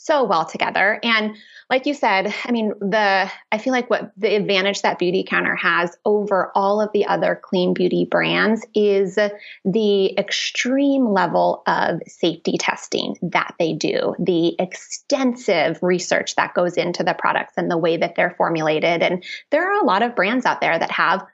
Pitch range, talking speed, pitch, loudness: 185-225 Hz, 175 wpm, 205 Hz, -19 LUFS